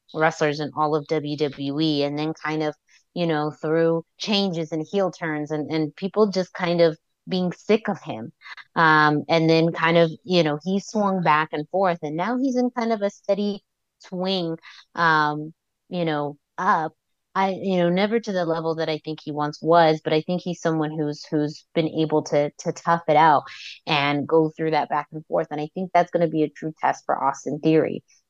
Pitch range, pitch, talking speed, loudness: 150-180 Hz, 160 Hz, 210 wpm, -23 LUFS